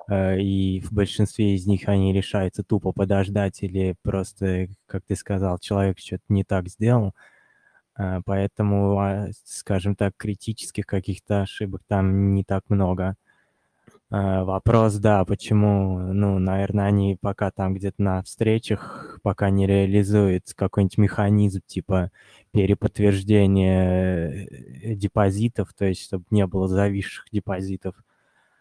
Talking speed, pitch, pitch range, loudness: 115 wpm, 100 Hz, 95-105 Hz, -23 LUFS